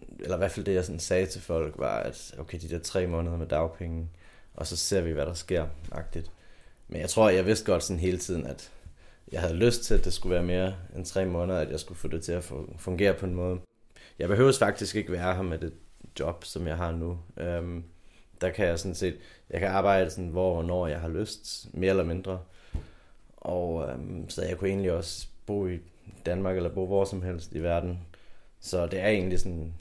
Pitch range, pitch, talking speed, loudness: 85-95 Hz, 90 Hz, 230 wpm, -30 LUFS